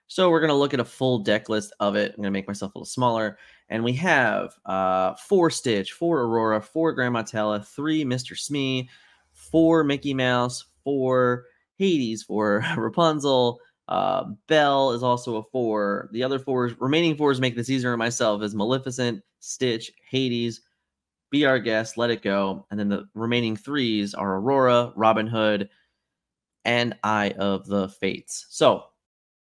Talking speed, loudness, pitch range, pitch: 160 wpm, -24 LUFS, 105-135 Hz, 120 Hz